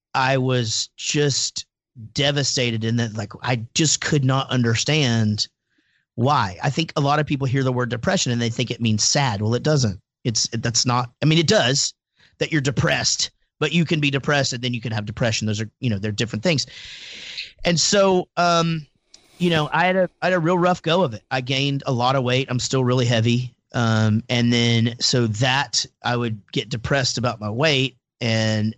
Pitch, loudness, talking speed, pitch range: 125 Hz, -21 LUFS, 205 wpm, 115-145 Hz